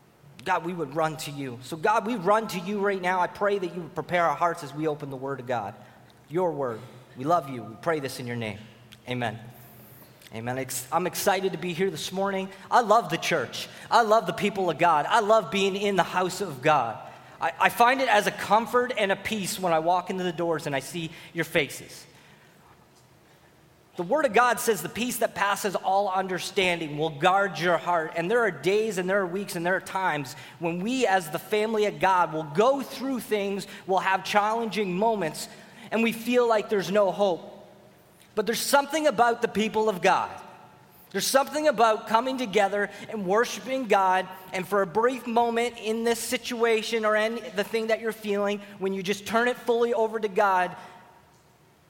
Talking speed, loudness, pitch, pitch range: 205 wpm, -26 LUFS, 195 Hz, 170-220 Hz